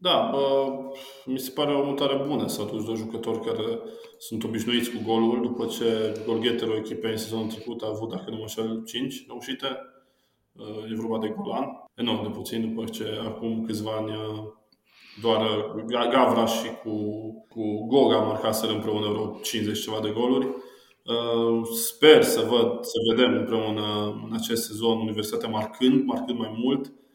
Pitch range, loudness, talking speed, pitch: 110-120 Hz, -26 LUFS, 155 wpm, 115 Hz